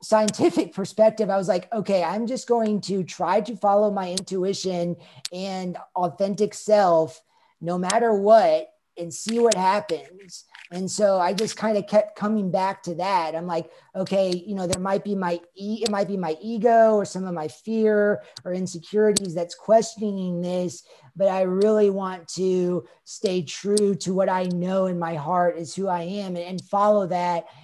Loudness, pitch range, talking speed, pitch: -23 LUFS, 180-210 Hz, 180 wpm, 190 Hz